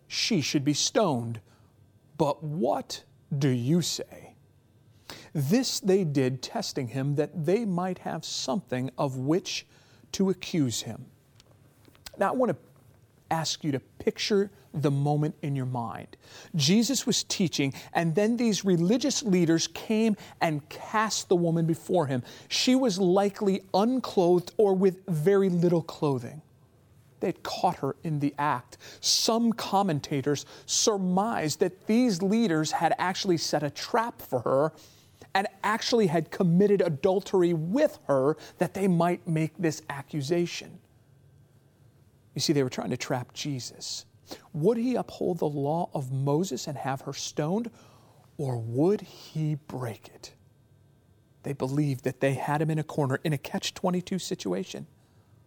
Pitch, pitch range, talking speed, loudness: 155 Hz, 130-190 Hz, 145 wpm, -27 LUFS